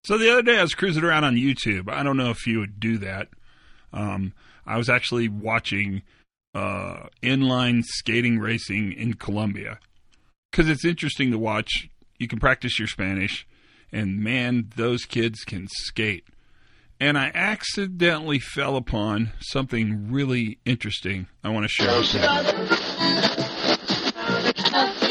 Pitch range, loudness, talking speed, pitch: 105-130 Hz, -23 LUFS, 140 wpm, 115 Hz